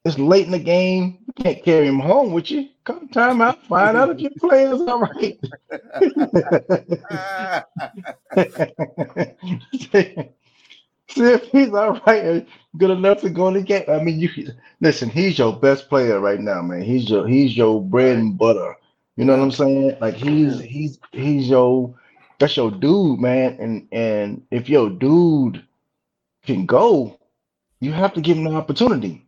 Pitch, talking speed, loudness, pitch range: 165 Hz, 170 wpm, -18 LUFS, 130-200 Hz